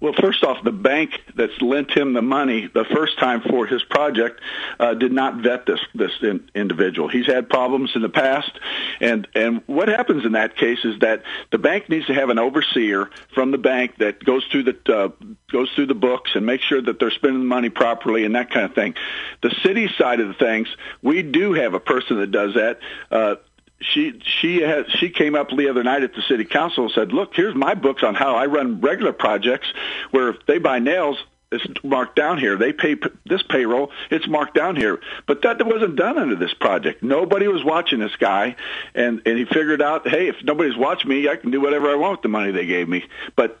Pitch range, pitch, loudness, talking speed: 115-150 Hz, 130 Hz, -19 LUFS, 230 wpm